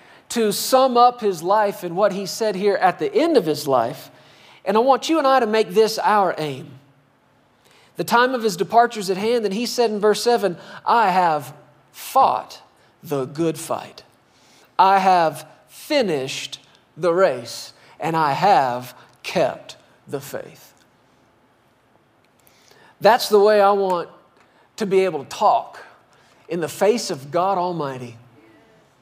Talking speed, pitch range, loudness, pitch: 155 wpm, 150-220 Hz, -19 LUFS, 195 Hz